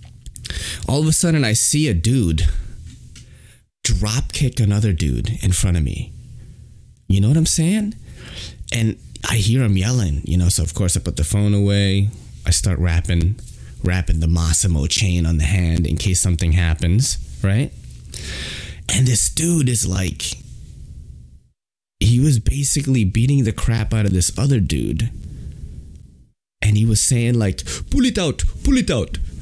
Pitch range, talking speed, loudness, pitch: 85-120 Hz, 160 wpm, -18 LUFS, 100 Hz